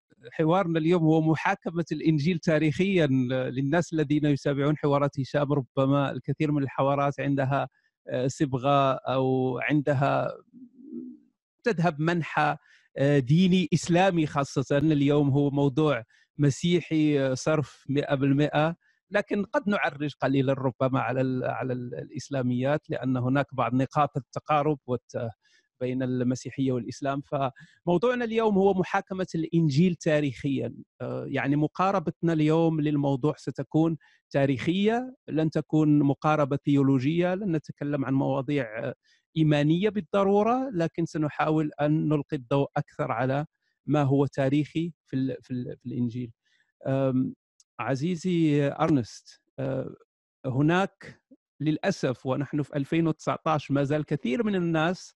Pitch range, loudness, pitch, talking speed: 135-165 Hz, -26 LUFS, 150 Hz, 105 wpm